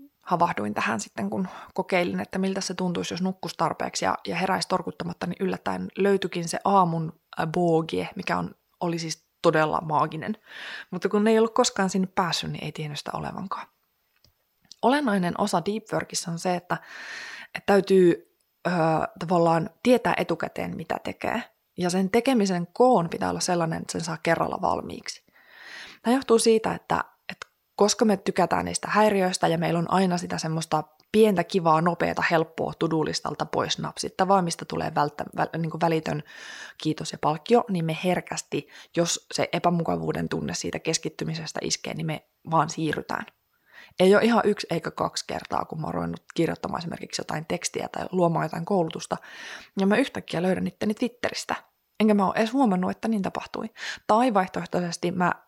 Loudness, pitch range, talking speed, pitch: -26 LUFS, 165-205 Hz, 160 wpm, 180 Hz